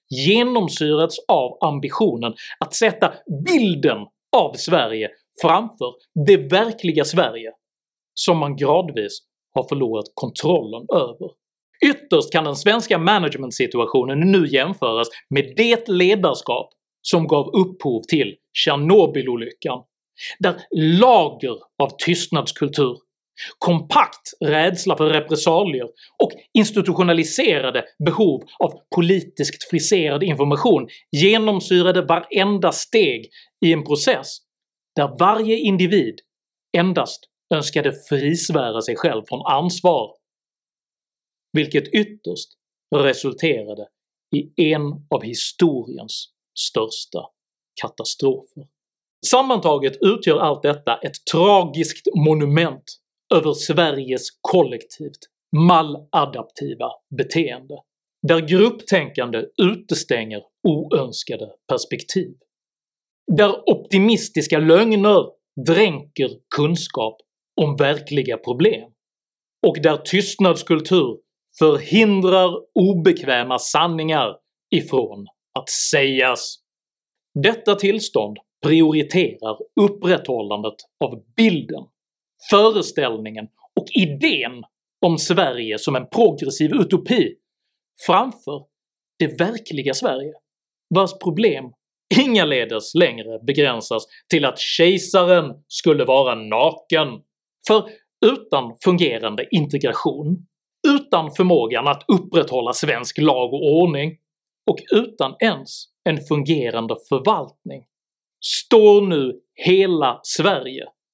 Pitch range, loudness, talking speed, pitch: 145-200 Hz, -19 LUFS, 85 wpm, 170 Hz